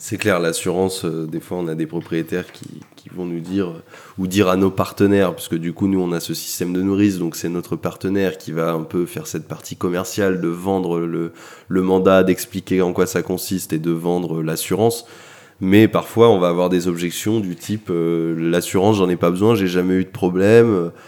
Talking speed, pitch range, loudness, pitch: 215 wpm, 85-95 Hz, -19 LUFS, 90 Hz